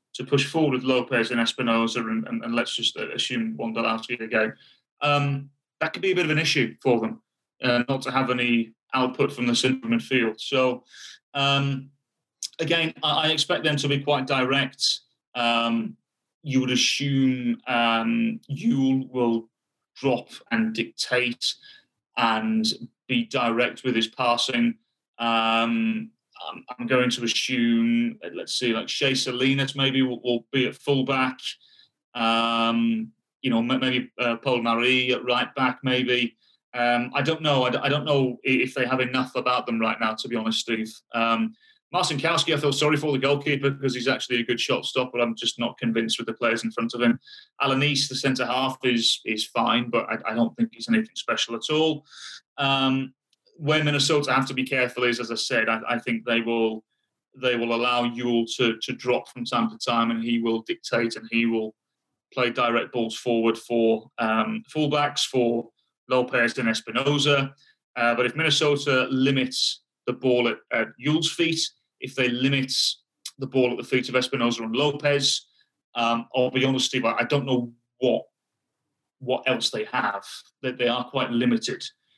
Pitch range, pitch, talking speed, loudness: 115-140 Hz, 125 Hz, 175 wpm, -24 LUFS